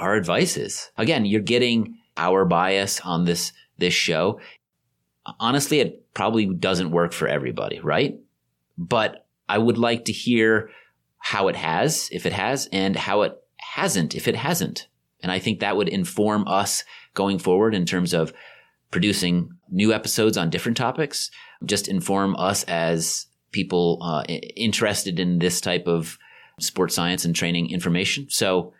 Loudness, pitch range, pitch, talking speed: -22 LUFS, 85-110 Hz, 95 Hz, 155 wpm